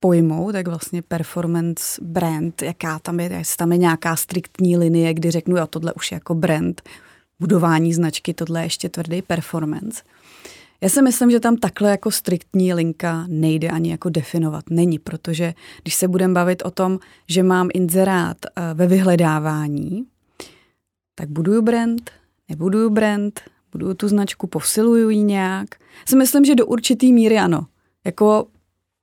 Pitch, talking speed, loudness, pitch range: 175 Hz, 155 wpm, -19 LUFS, 165-195 Hz